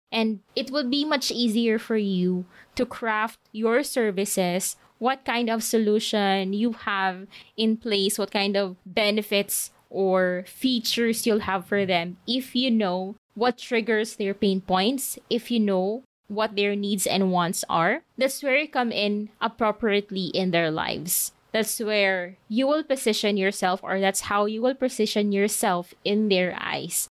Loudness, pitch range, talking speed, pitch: -24 LUFS, 195-235 Hz, 160 wpm, 210 Hz